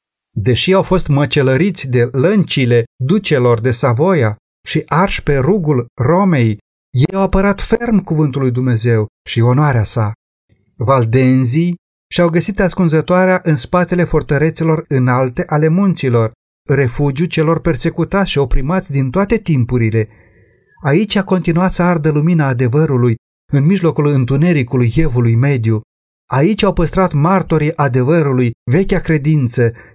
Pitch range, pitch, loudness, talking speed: 125-175 Hz, 145 Hz, -14 LUFS, 120 wpm